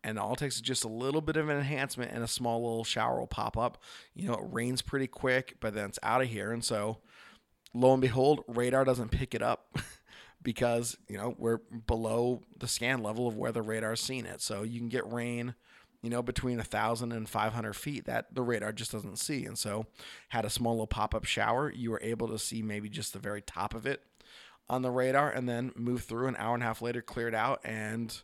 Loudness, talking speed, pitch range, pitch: -33 LUFS, 235 wpm, 110-125 Hz, 115 Hz